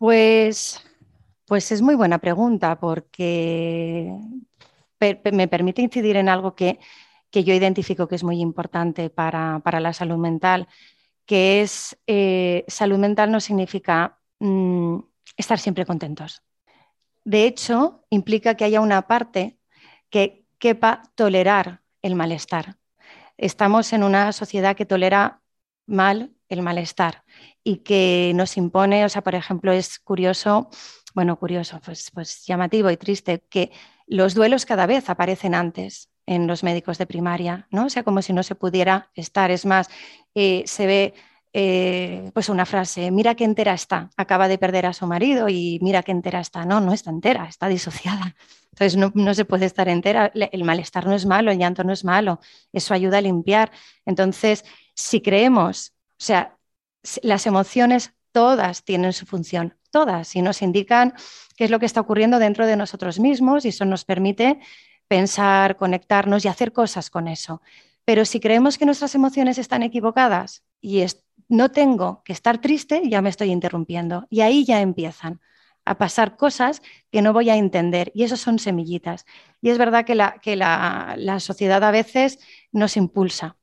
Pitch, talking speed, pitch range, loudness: 195 Hz, 165 wpm, 180-220 Hz, -20 LUFS